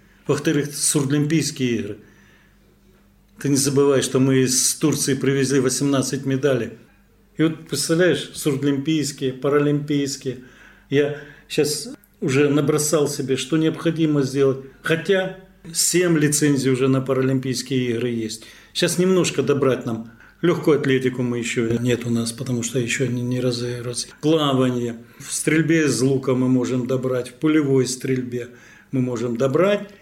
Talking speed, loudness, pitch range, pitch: 130 wpm, -20 LUFS, 125-150 Hz, 135 Hz